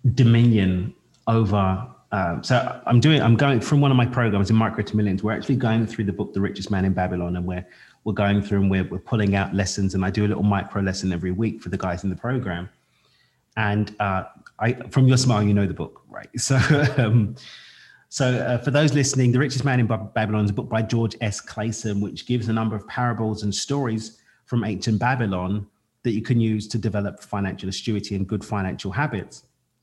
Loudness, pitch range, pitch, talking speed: -22 LUFS, 100-120 Hz, 110 Hz, 215 wpm